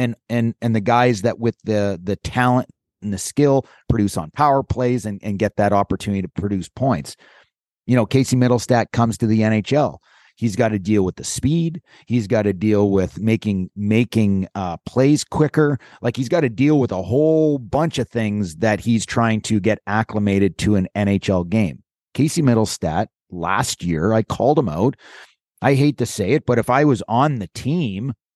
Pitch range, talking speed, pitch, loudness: 100-125 Hz, 195 wpm, 115 Hz, -19 LUFS